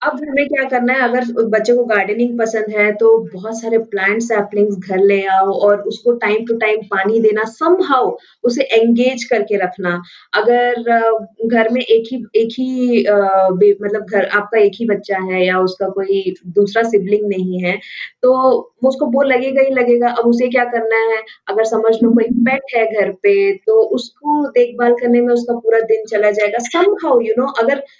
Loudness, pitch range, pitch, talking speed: -15 LUFS, 205-245 Hz, 225 Hz, 180 wpm